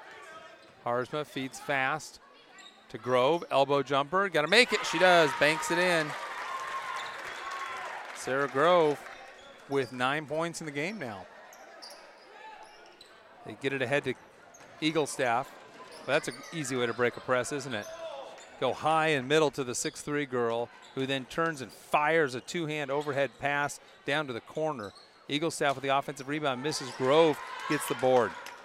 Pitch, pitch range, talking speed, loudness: 145 Hz, 130-155 Hz, 155 wpm, -29 LUFS